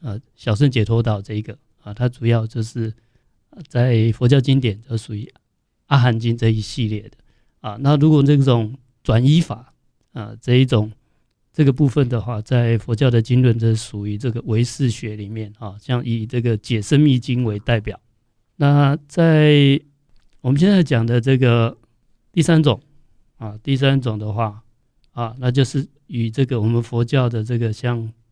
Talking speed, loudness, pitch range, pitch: 240 characters per minute, -18 LUFS, 115-135 Hz, 120 Hz